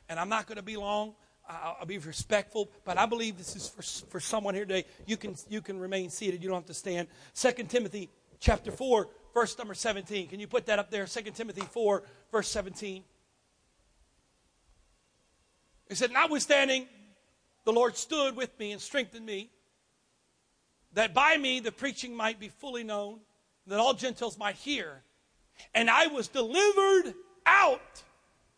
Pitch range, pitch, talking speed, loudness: 200-245 Hz, 215 Hz, 165 wpm, -30 LUFS